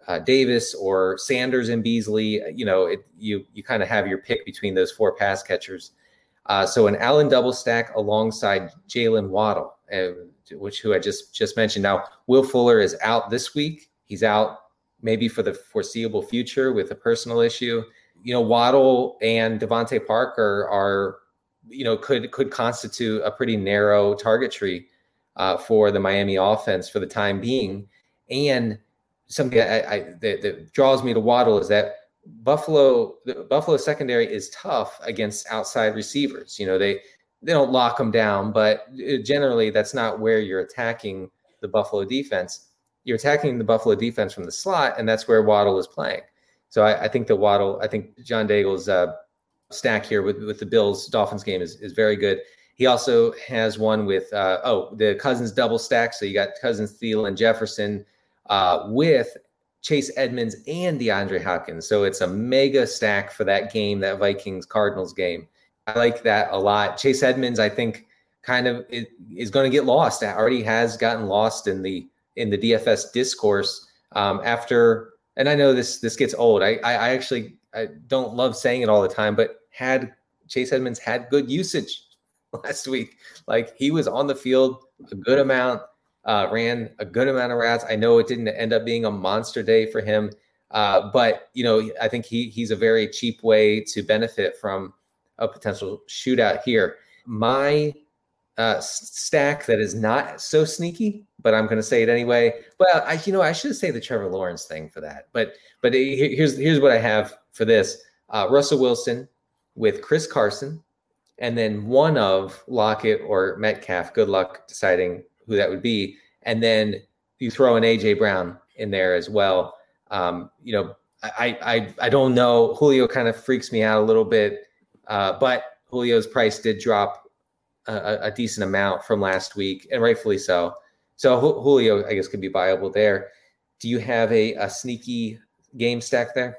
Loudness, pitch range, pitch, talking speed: -22 LUFS, 105-130 Hz, 115 Hz, 180 wpm